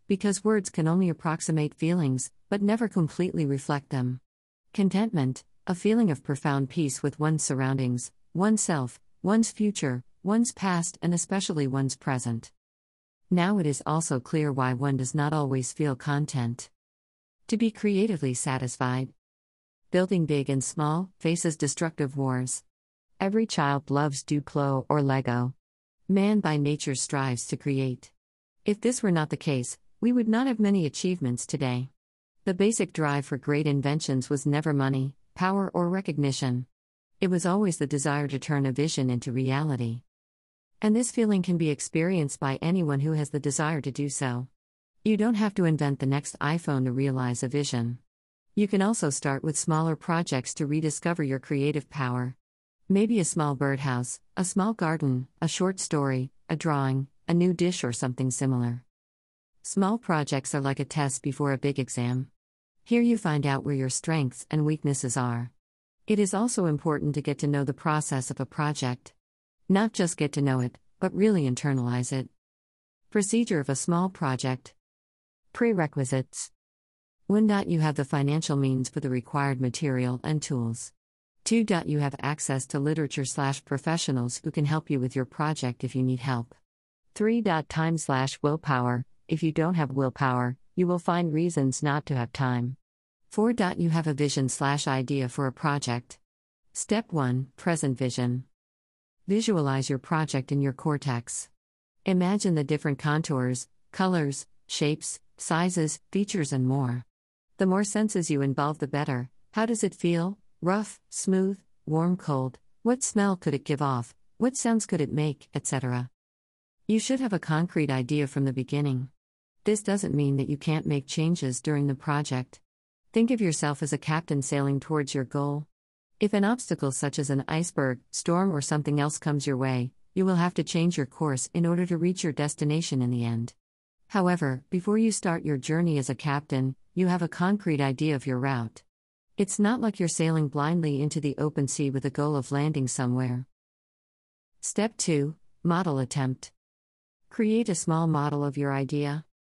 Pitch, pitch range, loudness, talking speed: 145 Hz, 130-170 Hz, -27 LUFS, 165 wpm